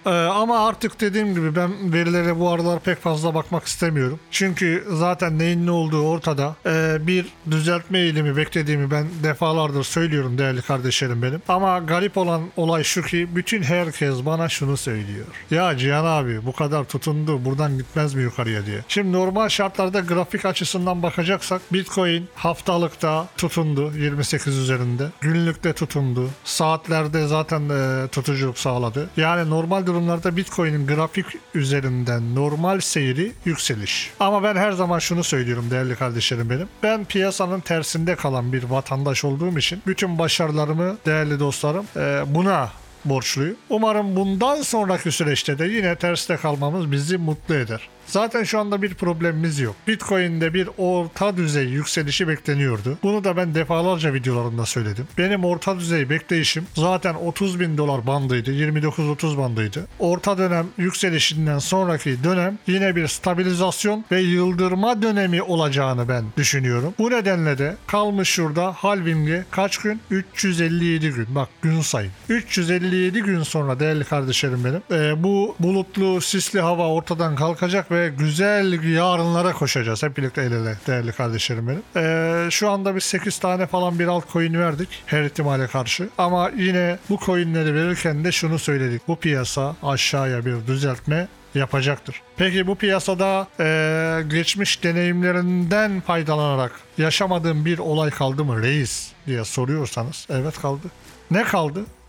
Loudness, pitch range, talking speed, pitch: -21 LUFS, 145-185 Hz, 140 wpm, 165 Hz